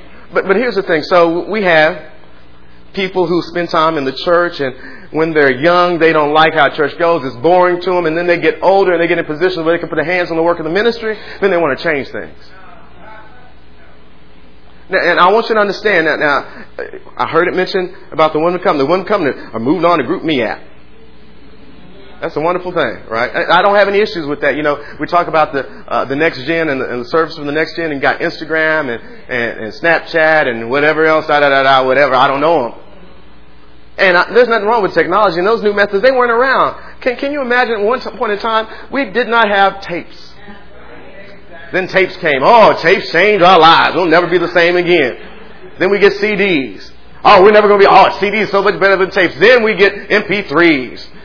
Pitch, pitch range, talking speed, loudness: 175 Hz, 155-200 Hz, 235 wpm, -12 LUFS